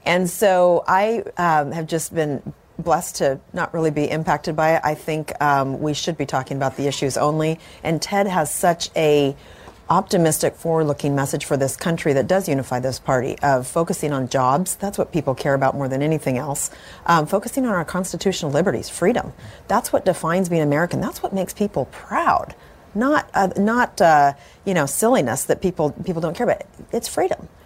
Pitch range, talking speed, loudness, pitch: 140-185 Hz, 190 wpm, -20 LUFS, 160 Hz